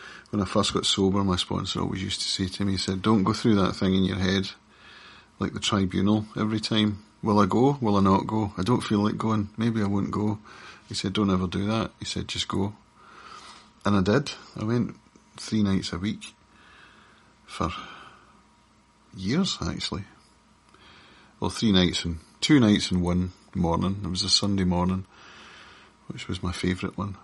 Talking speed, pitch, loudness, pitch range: 185 wpm, 100 Hz, -25 LUFS, 95-105 Hz